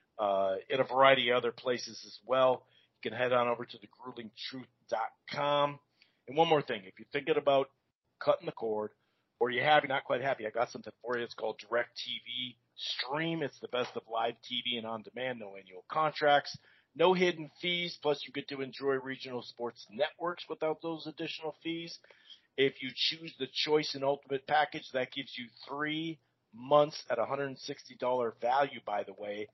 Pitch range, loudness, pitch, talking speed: 120-150 Hz, -33 LUFS, 135 Hz, 185 wpm